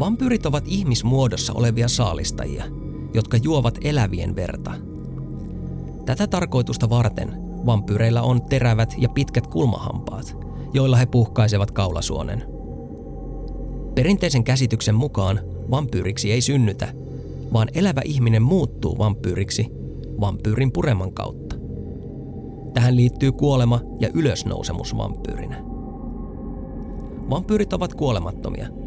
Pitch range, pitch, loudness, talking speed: 105-130 Hz, 120 Hz, -21 LUFS, 95 wpm